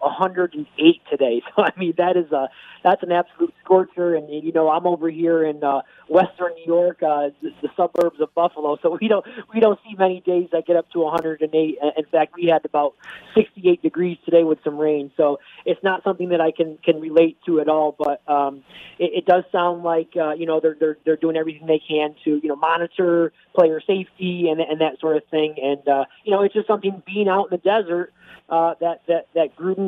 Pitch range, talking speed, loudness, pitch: 155-180 Hz, 220 wpm, -20 LUFS, 165 Hz